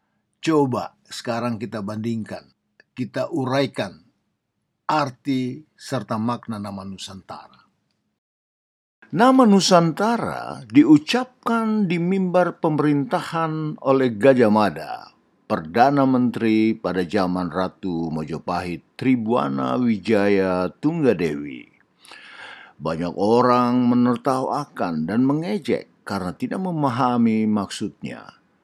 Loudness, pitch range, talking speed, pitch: -21 LUFS, 105-165 Hz, 80 wpm, 125 Hz